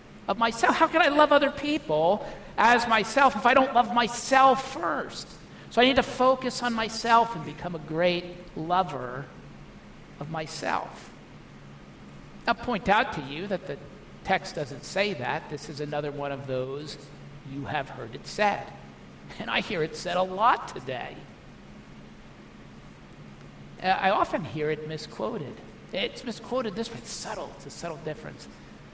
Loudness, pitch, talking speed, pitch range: -26 LUFS, 180 Hz, 155 wpm, 140-240 Hz